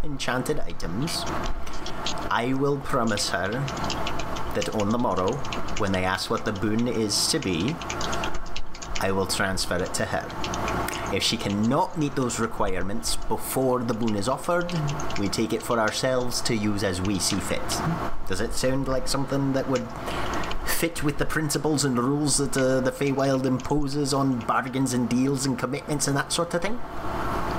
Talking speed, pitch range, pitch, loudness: 165 wpm, 115-140 Hz, 130 Hz, -26 LUFS